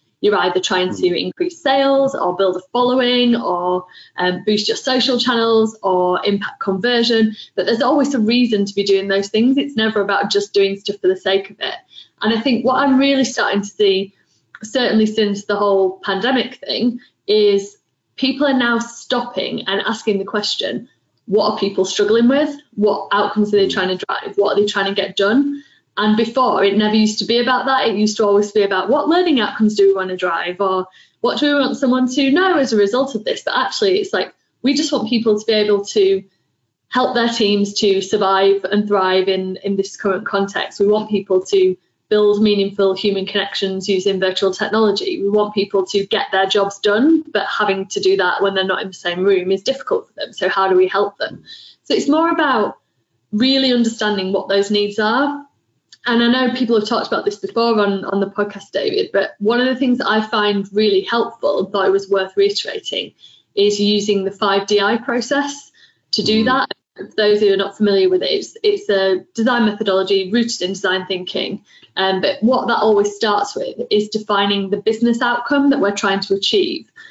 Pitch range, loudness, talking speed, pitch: 195-245 Hz, -17 LUFS, 205 wpm, 210 Hz